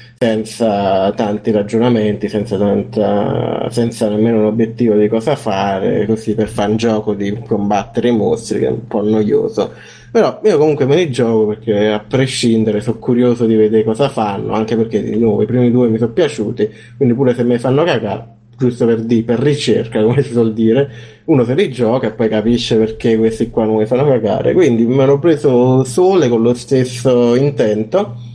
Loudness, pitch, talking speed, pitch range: -14 LUFS, 115 Hz, 190 wpm, 110-125 Hz